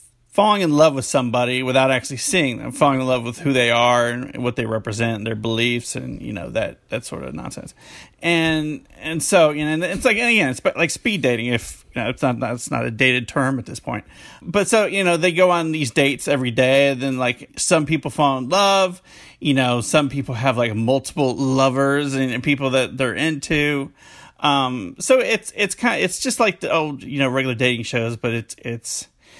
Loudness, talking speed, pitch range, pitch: -19 LUFS, 220 wpm, 125-160 Hz, 135 Hz